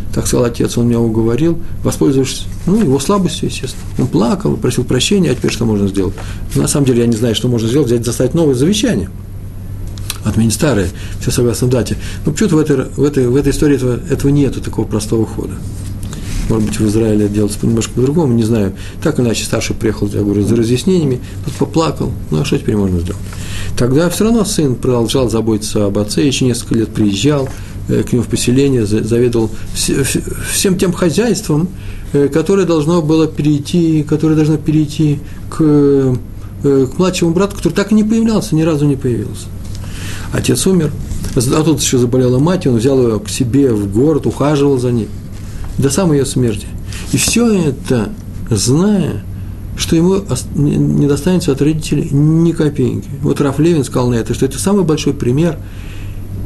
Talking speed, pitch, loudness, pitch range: 175 wpm, 125 Hz, -14 LUFS, 105-150 Hz